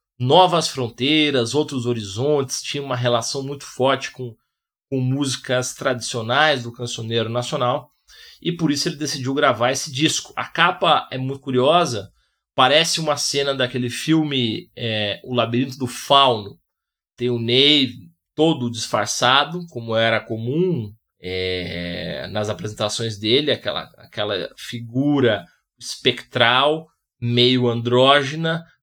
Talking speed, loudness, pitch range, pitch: 120 wpm, -20 LUFS, 120-145 Hz, 125 Hz